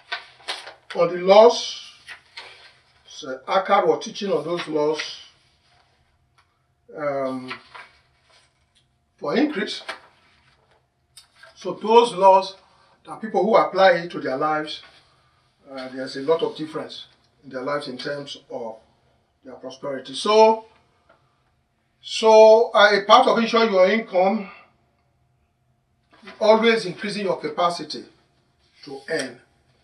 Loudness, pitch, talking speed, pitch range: -19 LUFS, 175 Hz, 105 wpm, 135-205 Hz